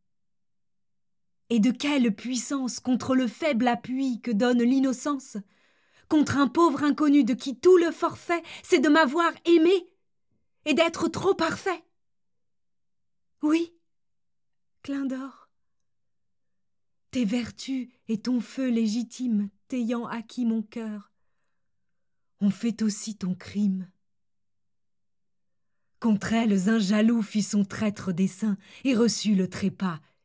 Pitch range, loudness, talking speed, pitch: 210-280 Hz, -25 LUFS, 115 wpm, 240 Hz